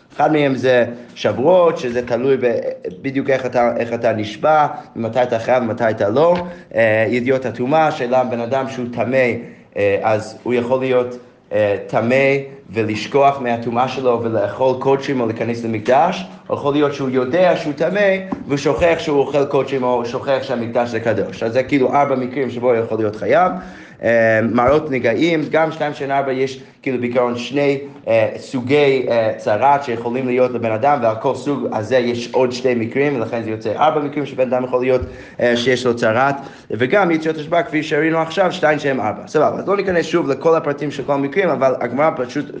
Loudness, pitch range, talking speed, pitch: -17 LUFS, 120-145 Hz, 180 wpm, 130 Hz